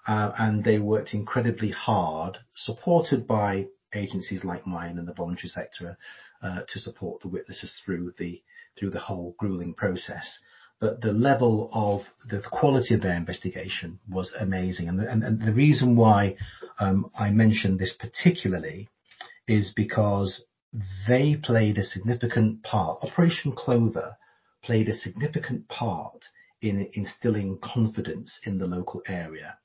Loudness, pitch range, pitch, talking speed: -26 LUFS, 95-115 Hz, 105 Hz, 145 wpm